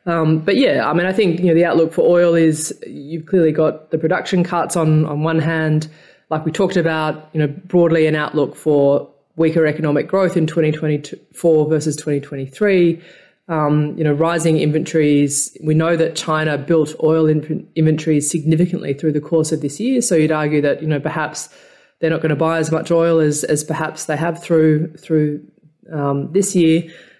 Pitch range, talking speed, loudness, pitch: 150-165 Hz, 190 wpm, -17 LUFS, 160 Hz